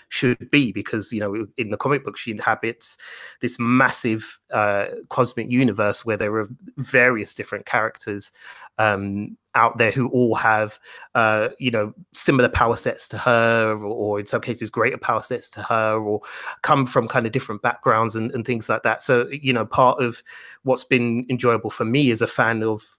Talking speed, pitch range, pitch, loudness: 190 wpm, 110-125 Hz, 115 Hz, -21 LUFS